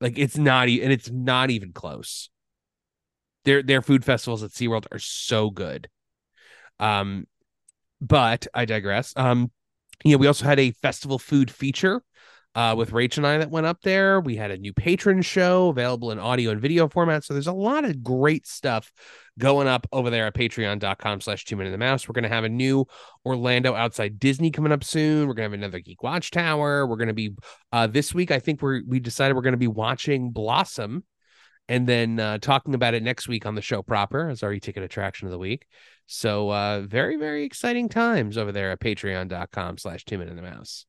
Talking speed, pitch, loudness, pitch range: 205 wpm, 125 Hz, -23 LUFS, 110-140 Hz